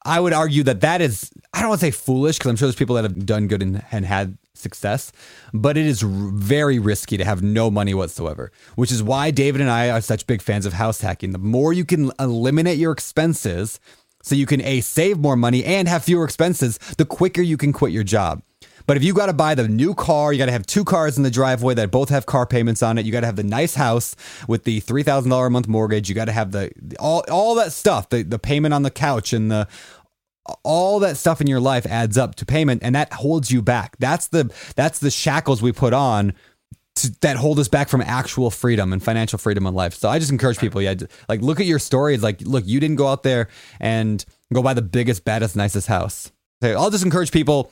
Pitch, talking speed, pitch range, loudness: 125 Hz, 250 wpm, 110-145 Hz, -19 LUFS